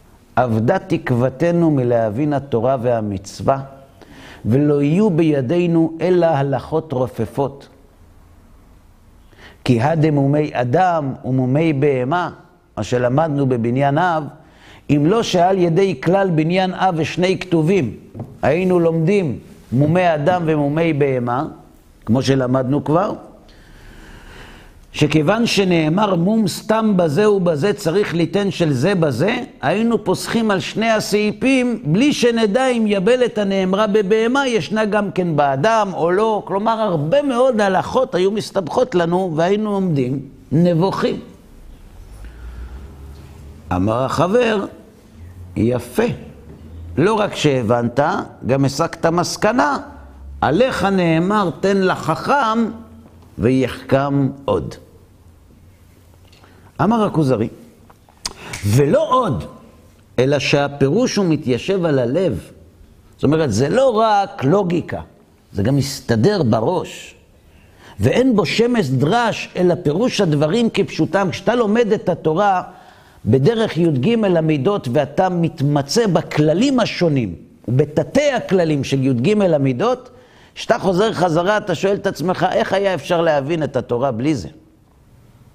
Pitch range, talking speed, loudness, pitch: 125-195 Hz, 105 wpm, -17 LUFS, 155 Hz